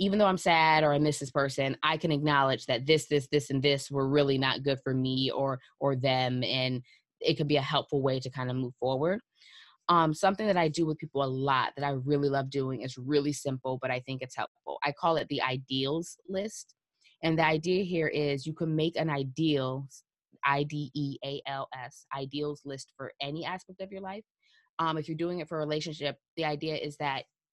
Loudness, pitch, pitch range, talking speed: -30 LUFS, 145 Hz, 135-160 Hz, 225 wpm